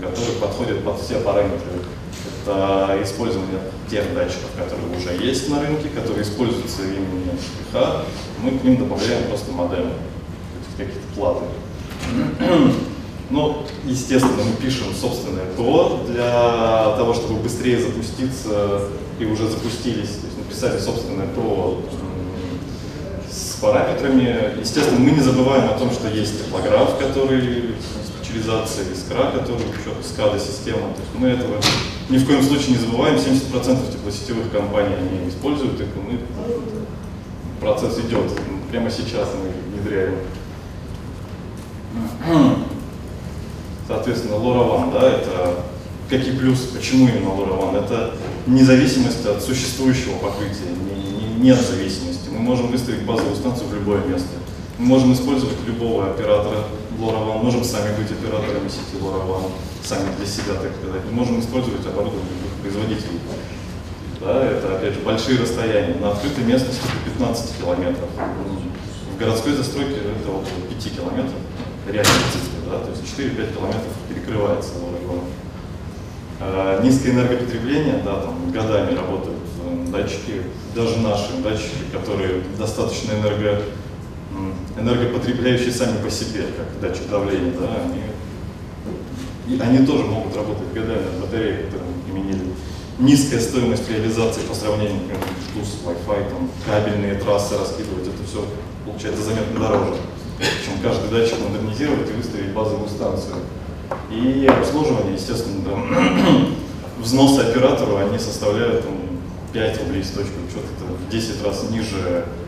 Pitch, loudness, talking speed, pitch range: 105 Hz, -21 LUFS, 125 wpm, 95-120 Hz